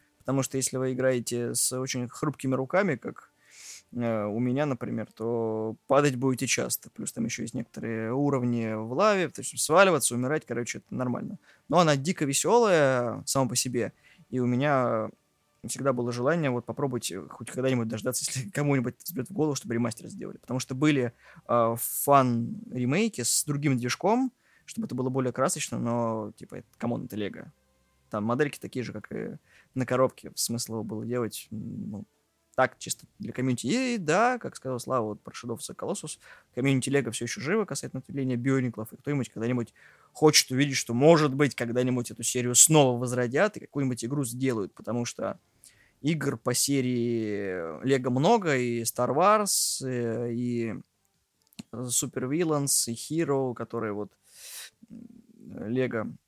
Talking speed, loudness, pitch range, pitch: 155 wpm, -27 LUFS, 120-145 Hz, 130 Hz